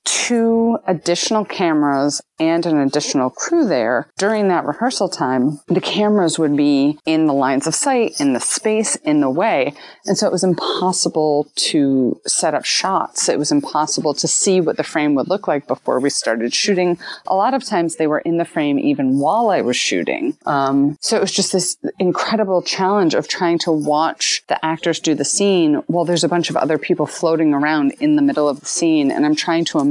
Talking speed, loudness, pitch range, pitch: 205 wpm, -17 LUFS, 150-215 Hz, 175 Hz